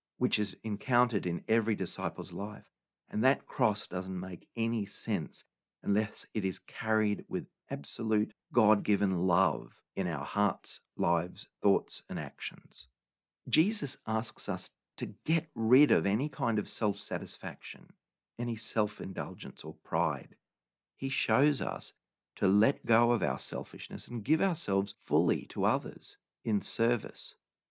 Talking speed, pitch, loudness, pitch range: 140 wpm, 110 Hz, -32 LUFS, 100-120 Hz